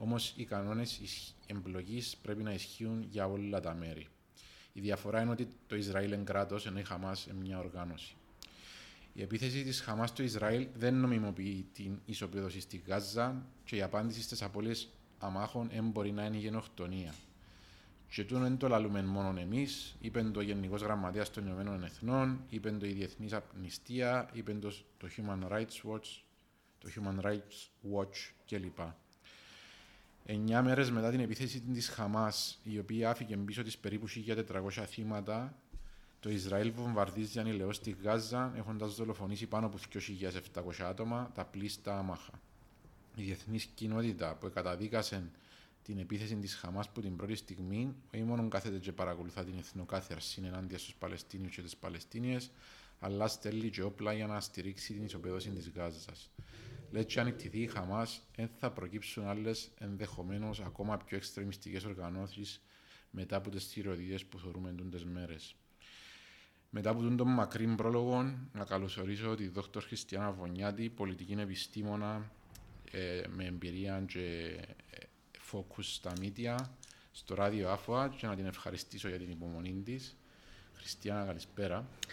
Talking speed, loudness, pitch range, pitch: 150 wpm, -39 LUFS, 95-110 Hz, 105 Hz